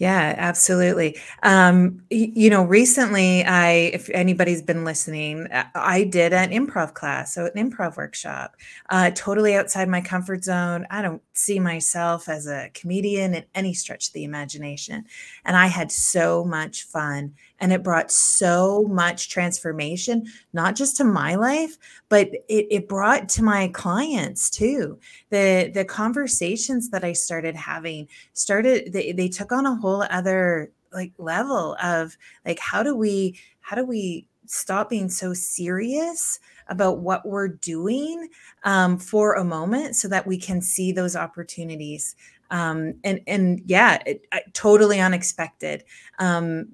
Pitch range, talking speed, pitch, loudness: 170-205 Hz, 150 wpm, 185 Hz, -21 LUFS